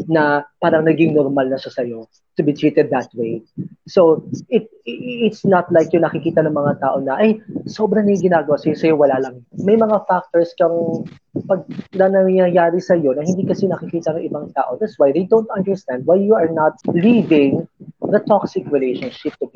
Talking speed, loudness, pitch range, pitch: 185 wpm, -17 LUFS, 150-190 Hz, 170 Hz